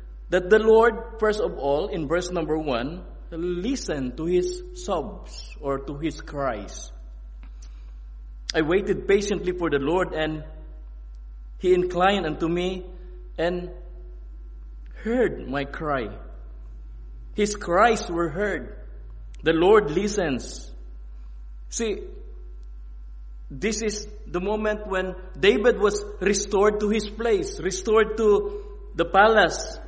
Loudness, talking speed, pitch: -24 LUFS, 110 wpm, 175 Hz